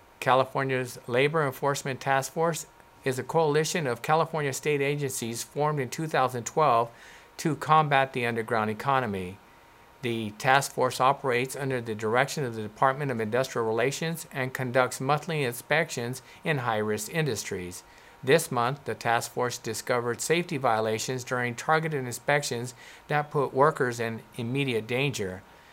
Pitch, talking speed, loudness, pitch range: 130 Hz, 135 wpm, -27 LUFS, 115-145 Hz